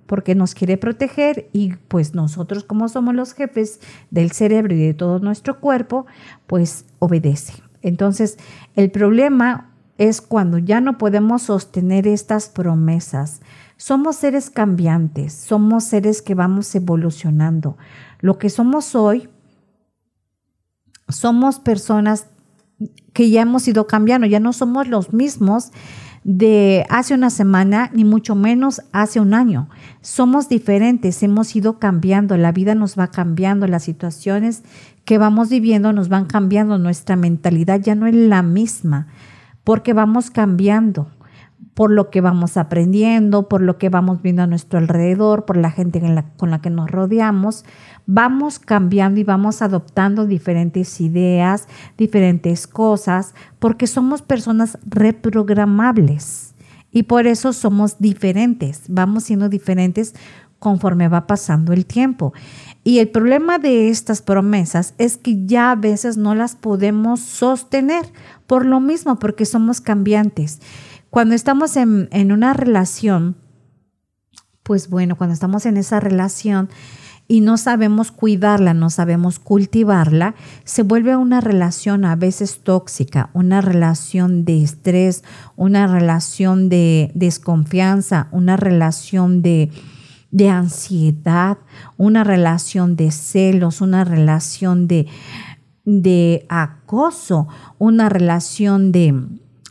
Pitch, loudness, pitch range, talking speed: 195 Hz, -16 LUFS, 170-220 Hz, 130 wpm